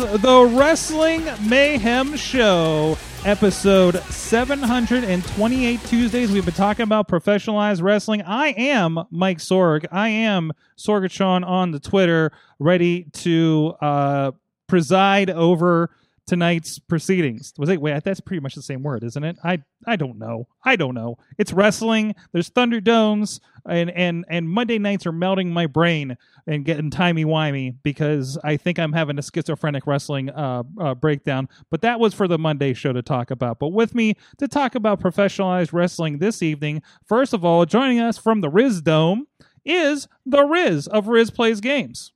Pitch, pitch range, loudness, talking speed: 180 Hz, 155-220 Hz, -20 LUFS, 160 wpm